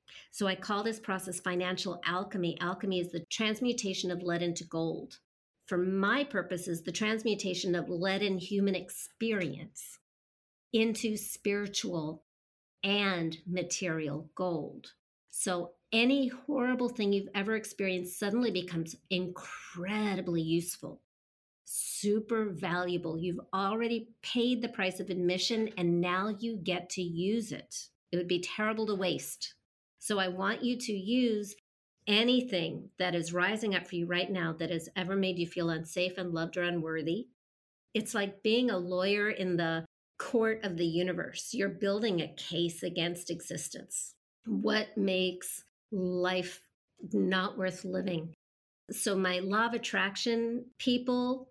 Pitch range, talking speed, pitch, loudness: 175-215 Hz, 135 wpm, 185 Hz, -33 LUFS